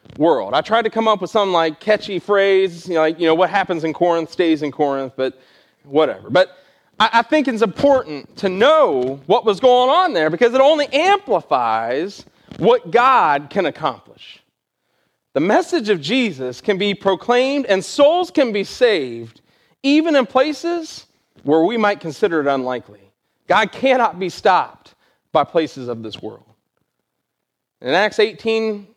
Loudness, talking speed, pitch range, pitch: -17 LUFS, 165 wpm, 160-250 Hz, 200 Hz